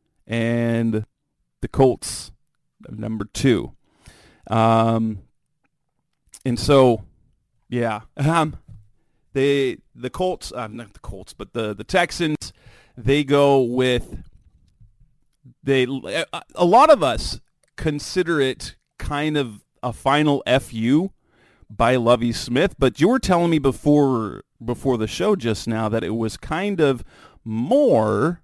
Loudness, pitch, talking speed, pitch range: -20 LUFS, 125 Hz, 120 wpm, 110-145 Hz